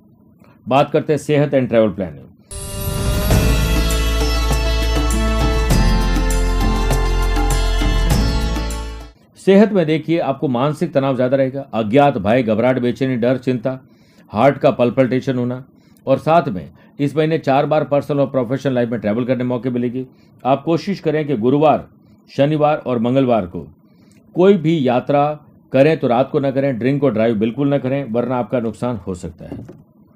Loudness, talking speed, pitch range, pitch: -17 LUFS, 140 wpm, 110-145 Hz, 130 Hz